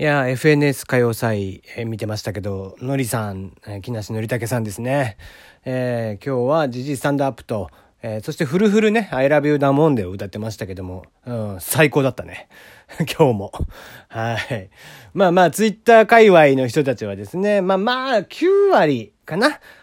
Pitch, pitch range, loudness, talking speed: 130 Hz, 110-155 Hz, -18 LUFS, 365 characters per minute